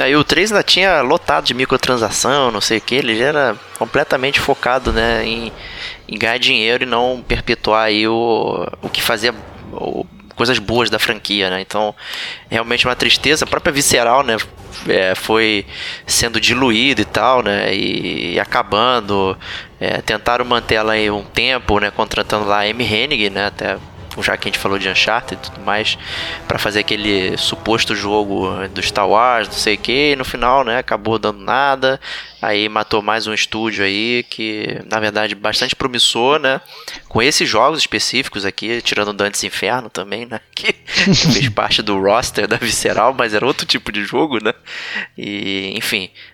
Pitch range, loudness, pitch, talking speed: 105-120 Hz, -15 LUFS, 110 Hz, 175 wpm